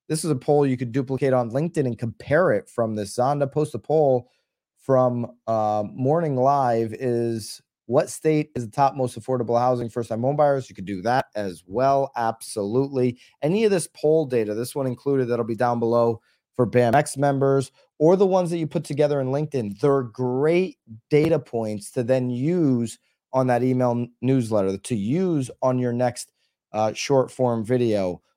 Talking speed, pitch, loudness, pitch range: 185 wpm, 130 Hz, -23 LUFS, 120-145 Hz